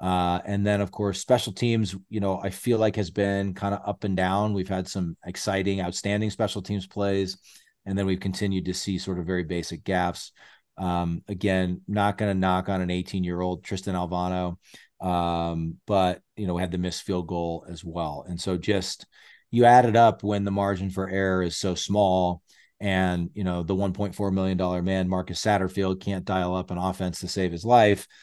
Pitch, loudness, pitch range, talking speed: 95 Hz, -26 LUFS, 90-100 Hz, 200 wpm